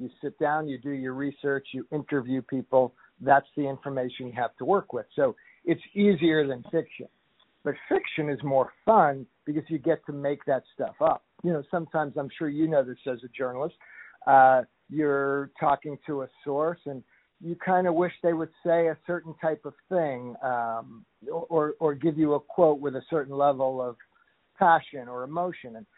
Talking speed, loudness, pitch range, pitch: 190 wpm, -27 LUFS, 130-160 Hz, 145 Hz